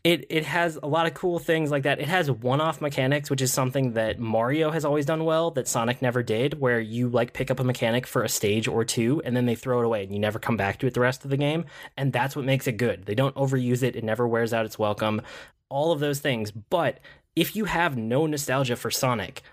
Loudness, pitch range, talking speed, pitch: -25 LUFS, 115-150 Hz, 260 wpm, 130 Hz